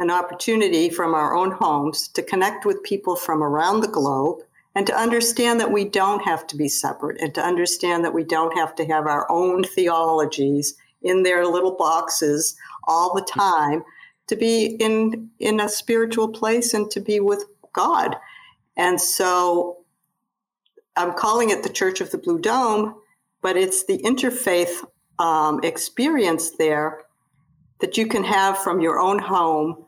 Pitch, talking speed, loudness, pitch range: 180 Hz, 165 wpm, -21 LUFS, 165-220 Hz